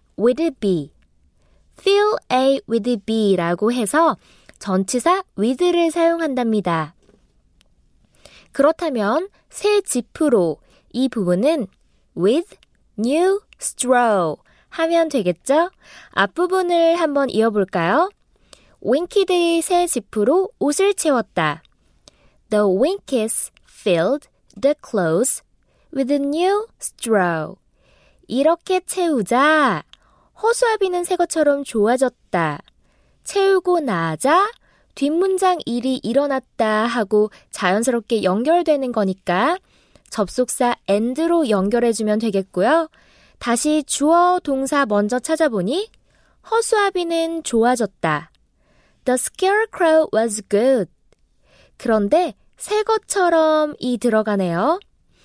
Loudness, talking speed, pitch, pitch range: -19 LUFS, 265 characters per minute, 275 Hz, 220-340 Hz